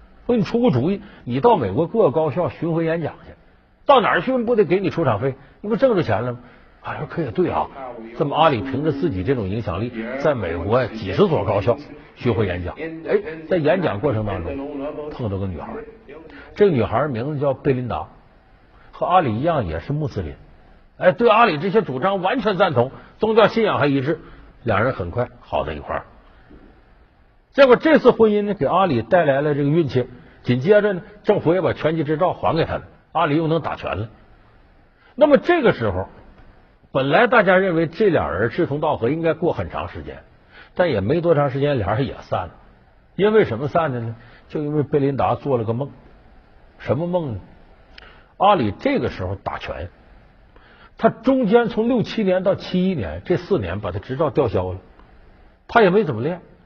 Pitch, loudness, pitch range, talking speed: 150 Hz, -20 LUFS, 120-185 Hz, 280 characters per minute